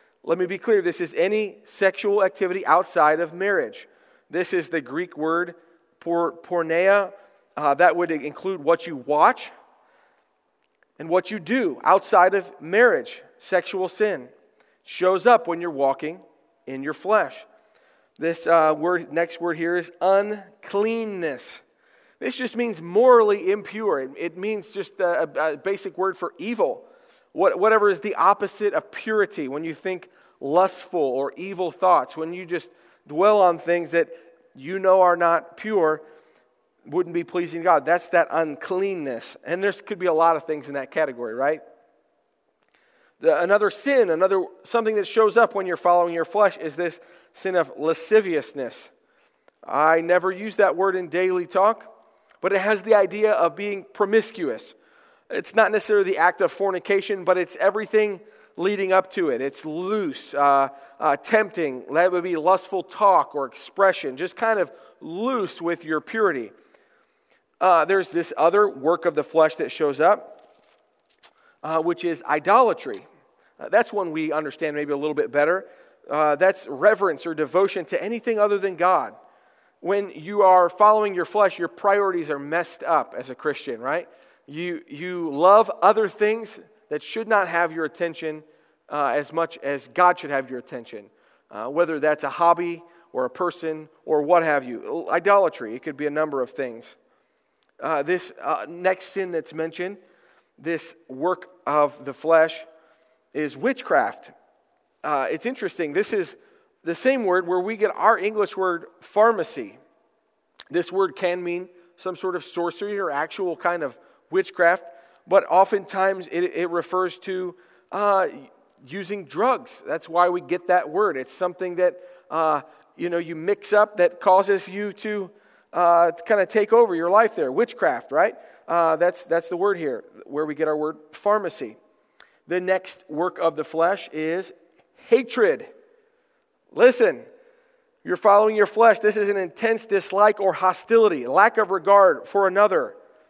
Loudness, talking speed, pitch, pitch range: -22 LUFS, 160 wpm, 185 Hz, 165-210 Hz